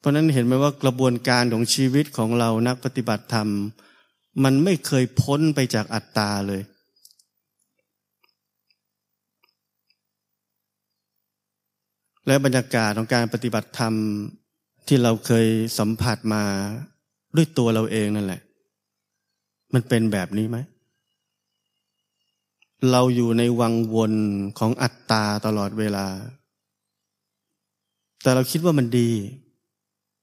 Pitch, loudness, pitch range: 115 Hz, -22 LUFS, 105-130 Hz